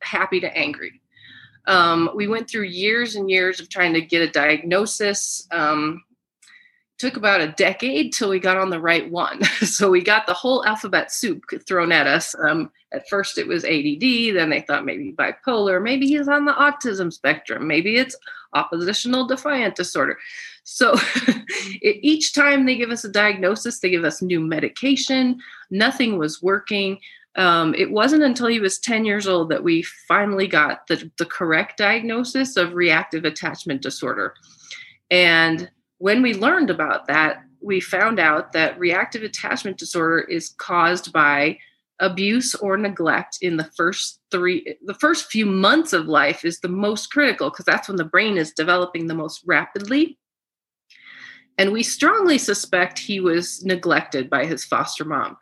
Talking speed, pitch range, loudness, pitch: 165 wpm, 175-255 Hz, -19 LUFS, 200 Hz